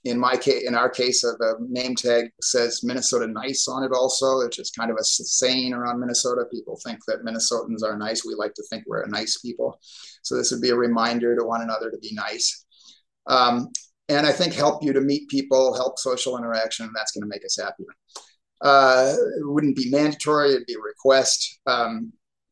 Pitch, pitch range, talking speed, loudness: 125 Hz, 120-135 Hz, 205 wpm, -22 LUFS